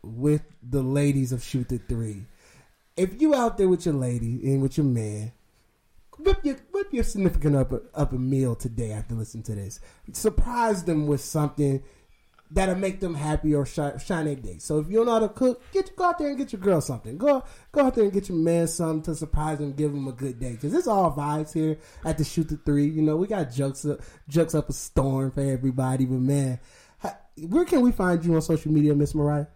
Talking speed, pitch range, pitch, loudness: 225 wpm, 130-180 Hz, 150 Hz, -25 LUFS